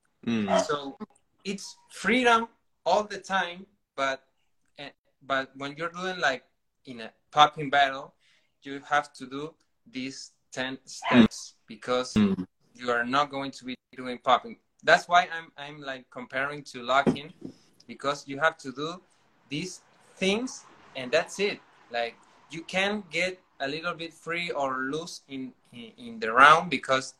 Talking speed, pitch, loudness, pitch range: 145 wpm, 145 Hz, -27 LUFS, 135-185 Hz